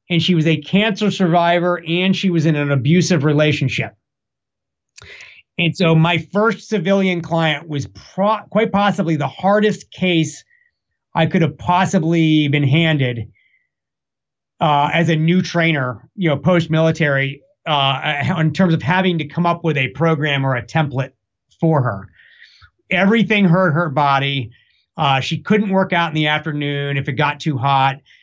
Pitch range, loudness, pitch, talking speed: 145-180 Hz, -17 LUFS, 160 Hz, 155 wpm